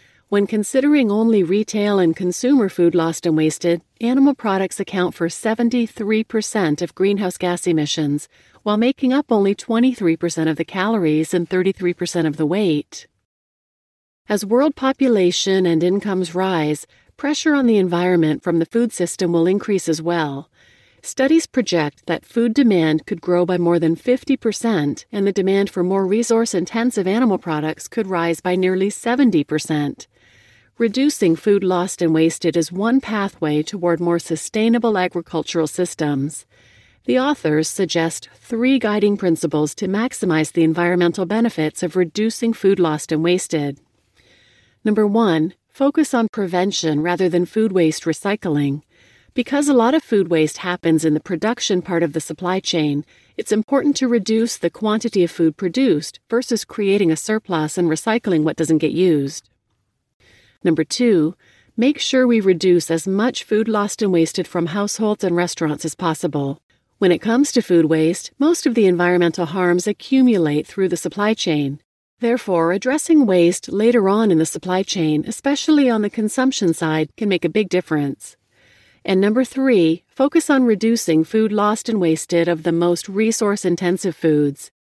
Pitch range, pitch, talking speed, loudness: 165-220 Hz, 180 Hz, 155 wpm, -18 LUFS